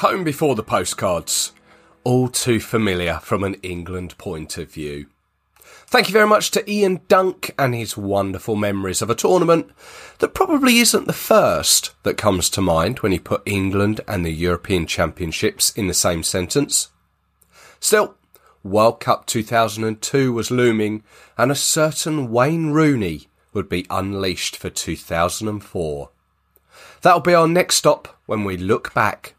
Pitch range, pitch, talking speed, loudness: 90-145 Hz, 105 Hz, 150 wpm, -19 LUFS